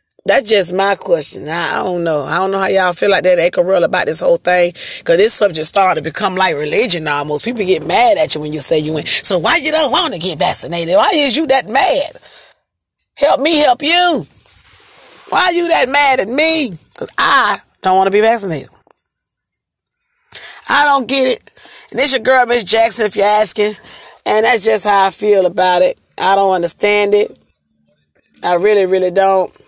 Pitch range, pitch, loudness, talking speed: 180-270 Hz, 205 Hz, -12 LUFS, 200 wpm